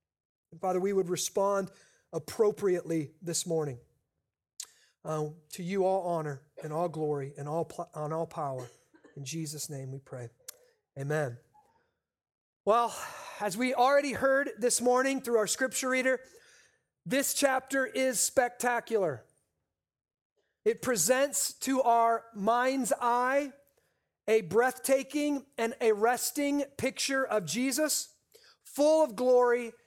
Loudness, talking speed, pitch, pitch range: -30 LUFS, 120 wpm, 235 Hz, 165-265 Hz